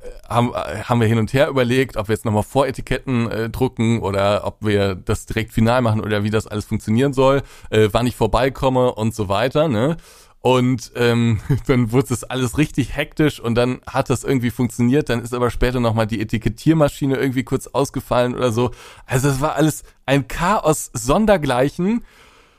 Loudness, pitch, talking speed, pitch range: -19 LUFS, 125 Hz, 180 wpm, 115-135 Hz